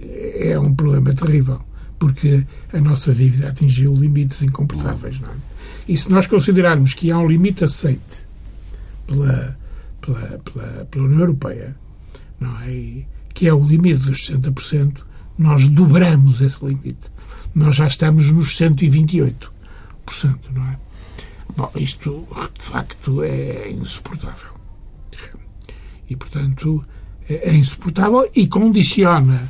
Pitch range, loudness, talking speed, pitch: 125-155 Hz, -16 LUFS, 120 wpm, 140 Hz